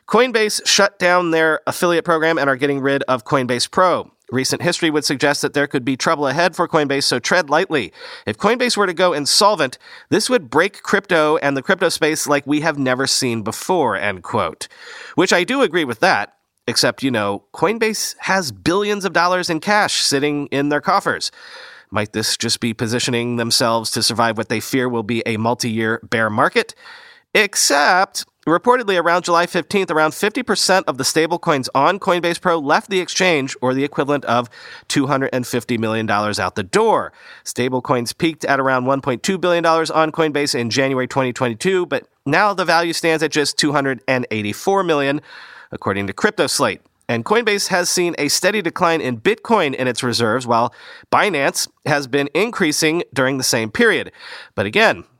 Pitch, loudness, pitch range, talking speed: 145 Hz, -17 LUFS, 125-175 Hz, 170 wpm